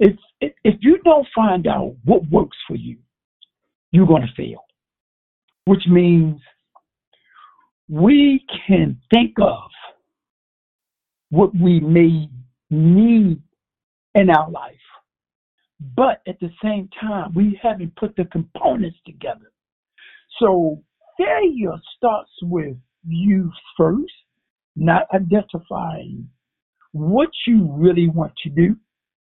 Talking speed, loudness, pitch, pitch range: 105 wpm, -17 LUFS, 185 Hz, 165-215 Hz